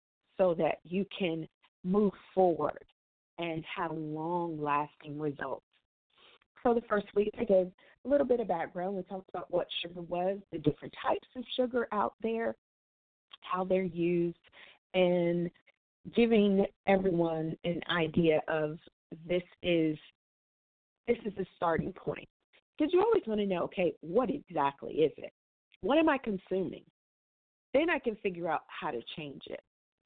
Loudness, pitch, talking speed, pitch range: -32 LUFS, 180 Hz, 150 wpm, 165-210 Hz